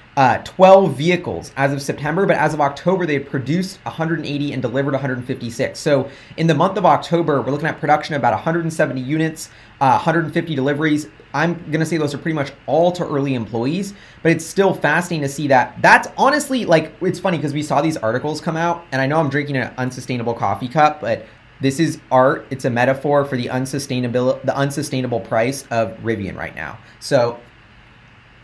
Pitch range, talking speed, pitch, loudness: 130-160 Hz, 190 wpm, 145 Hz, -18 LUFS